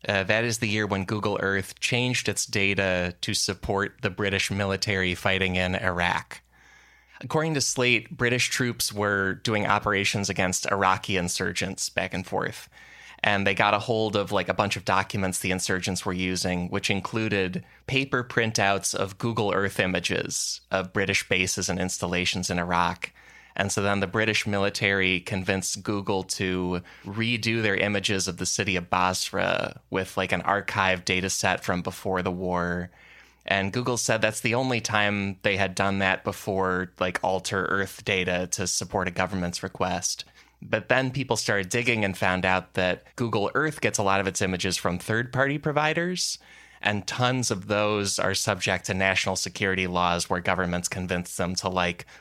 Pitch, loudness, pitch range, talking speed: 100 Hz, -25 LUFS, 95-110 Hz, 170 wpm